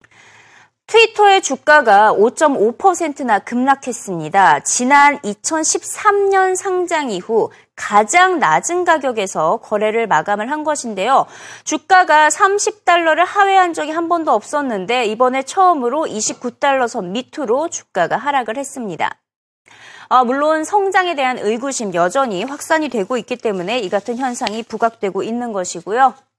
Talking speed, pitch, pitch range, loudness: 275 characters per minute, 270 Hz, 225-345 Hz, -15 LUFS